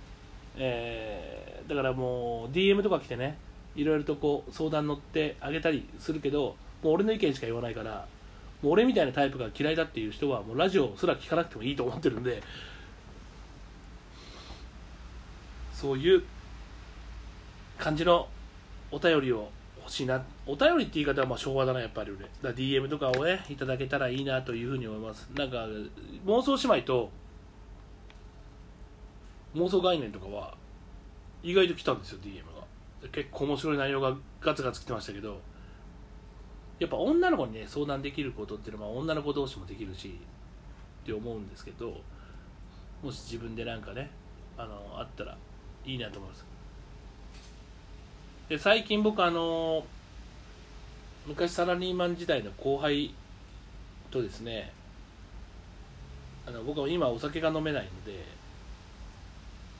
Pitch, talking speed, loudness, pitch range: 125 Hz, 295 characters per minute, -31 LUFS, 100-150 Hz